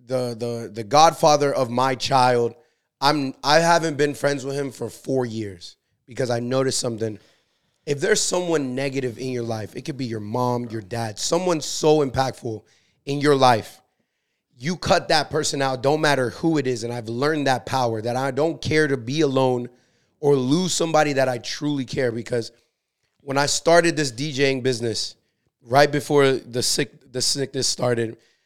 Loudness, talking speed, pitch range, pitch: -22 LUFS, 175 wpm, 120-145 Hz, 135 Hz